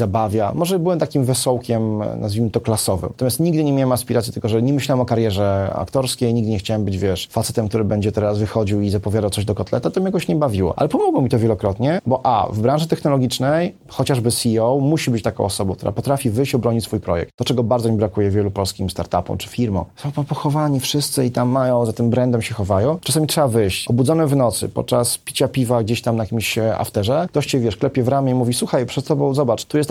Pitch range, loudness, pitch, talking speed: 110-140 Hz, -19 LUFS, 120 Hz, 225 wpm